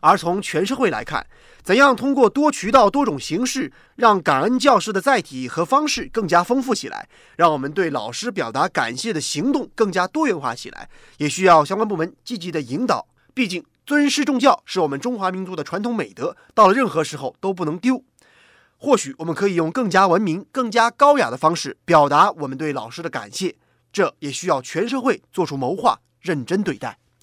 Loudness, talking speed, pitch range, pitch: -19 LUFS, 305 characters per minute, 165-260 Hz, 200 Hz